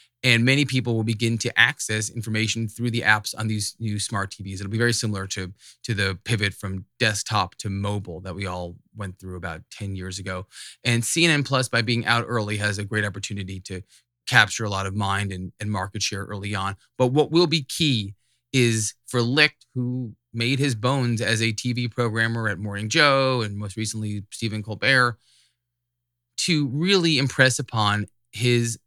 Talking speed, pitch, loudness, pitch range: 185 wpm, 110 Hz, -23 LUFS, 100-120 Hz